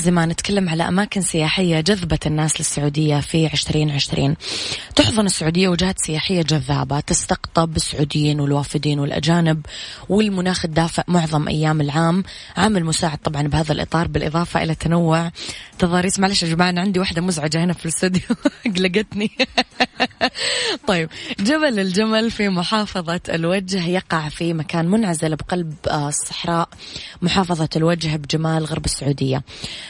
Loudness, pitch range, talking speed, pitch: -19 LUFS, 155-185 Hz, 120 wpm, 170 Hz